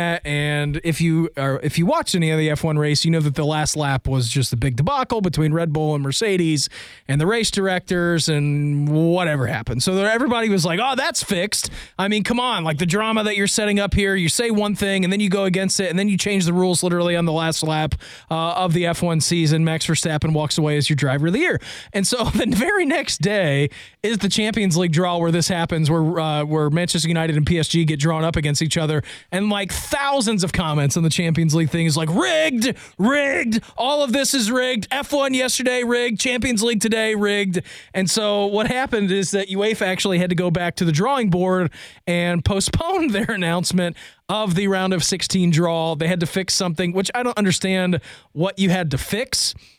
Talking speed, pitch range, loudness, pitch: 220 wpm, 160-205 Hz, -20 LUFS, 180 Hz